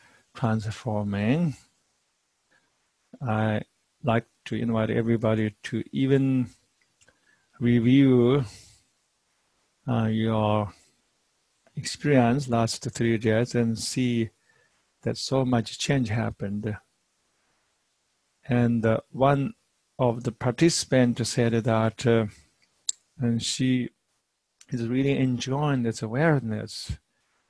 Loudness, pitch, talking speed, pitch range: -25 LUFS, 115 Hz, 85 wpm, 110-125 Hz